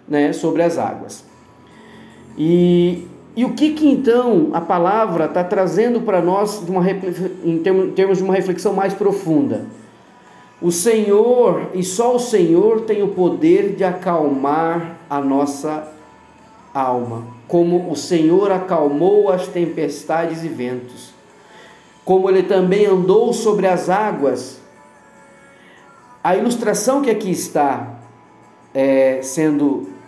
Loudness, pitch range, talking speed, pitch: -17 LUFS, 155-205 Hz, 125 wpm, 180 Hz